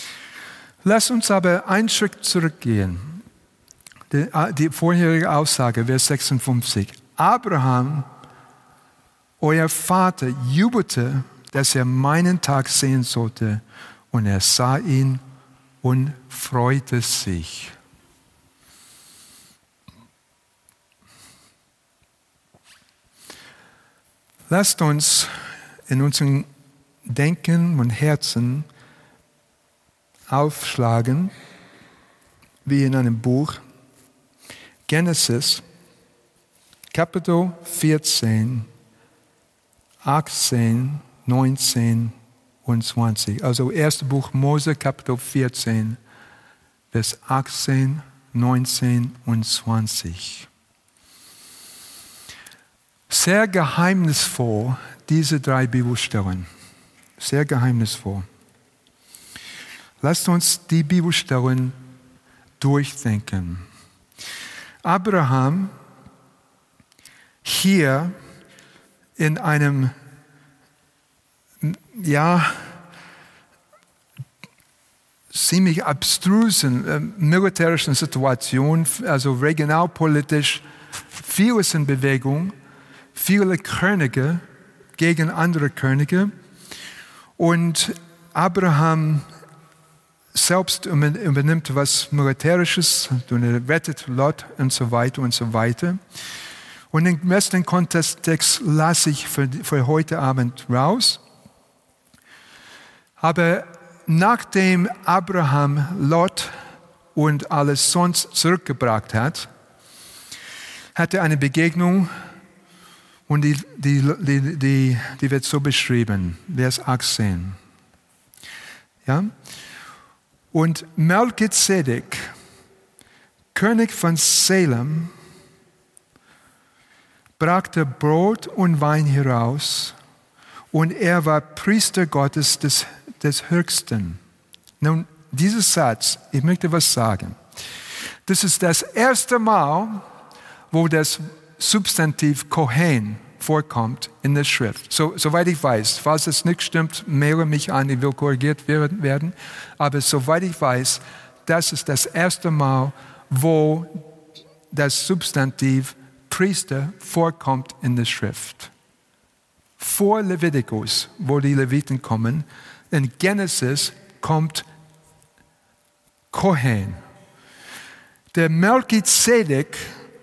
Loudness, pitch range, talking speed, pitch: -19 LUFS, 130-170 Hz, 80 wpm, 150 Hz